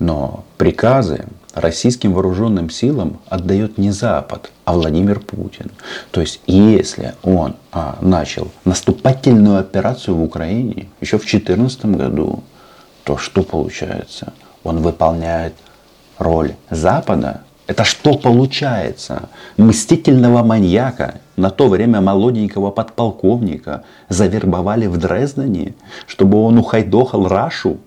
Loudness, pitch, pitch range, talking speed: -15 LUFS, 100 Hz, 90-115 Hz, 105 wpm